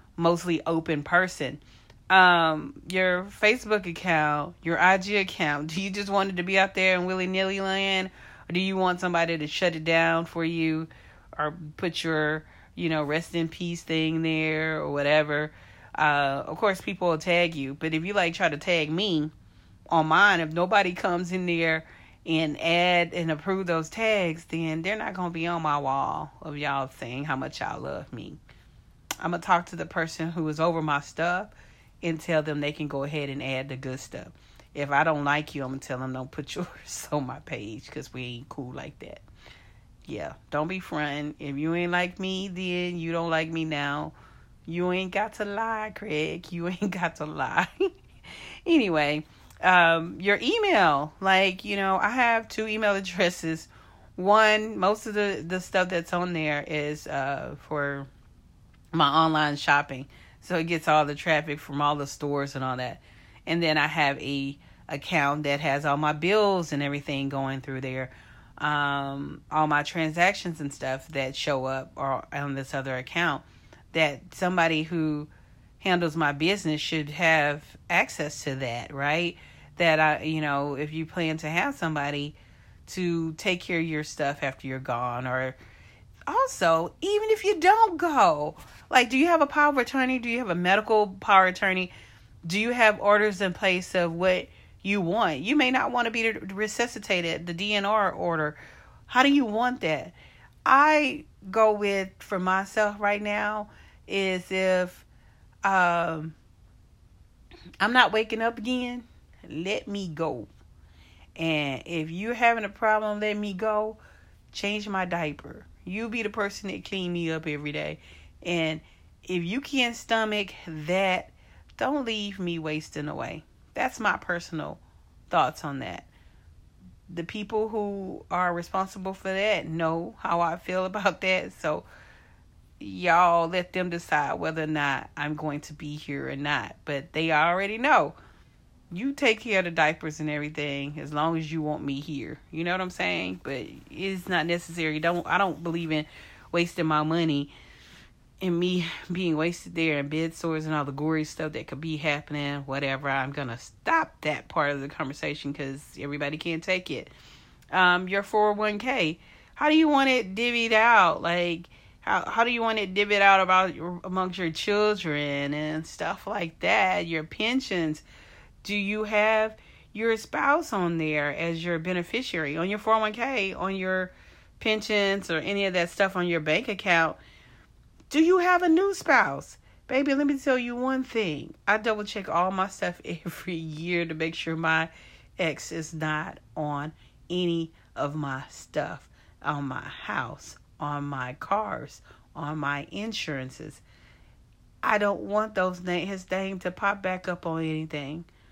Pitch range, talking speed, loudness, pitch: 145-195 Hz, 170 wpm, -26 LUFS, 165 Hz